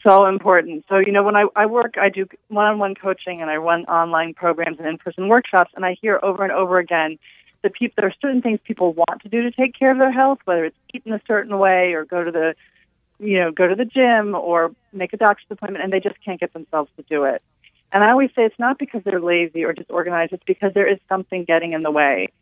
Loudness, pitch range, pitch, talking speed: -19 LUFS, 170-210 Hz, 190 Hz, 255 wpm